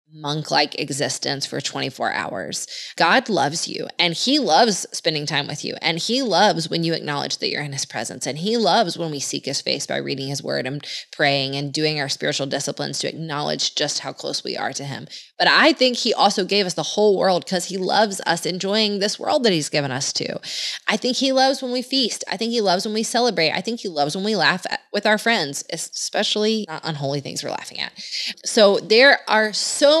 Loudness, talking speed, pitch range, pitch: -20 LUFS, 225 wpm, 145-220 Hz, 180 Hz